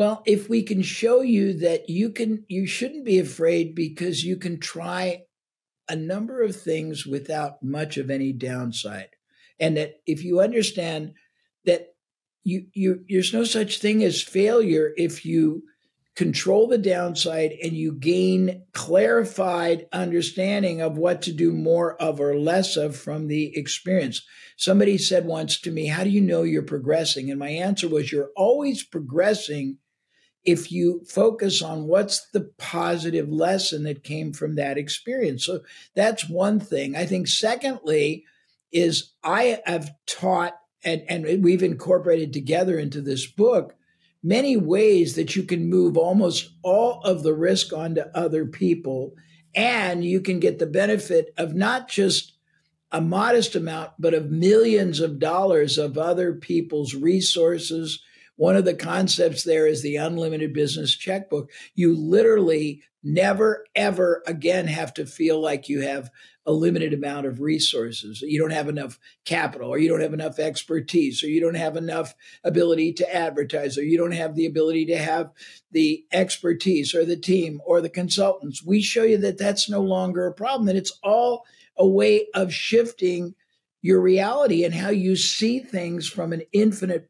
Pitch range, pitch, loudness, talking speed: 155-190 Hz, 170 Hz, -22 LUFS, 160 wpm